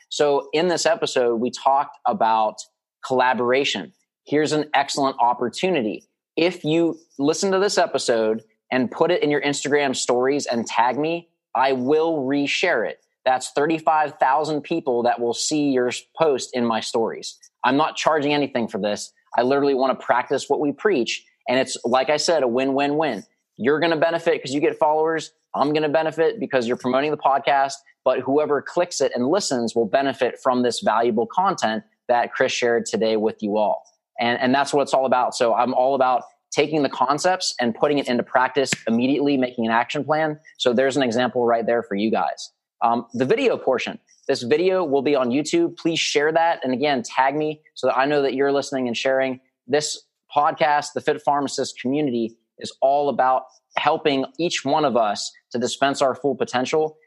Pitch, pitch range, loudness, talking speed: 140 Hz, 125-155 Hz, -21 LUFS, 190 wpm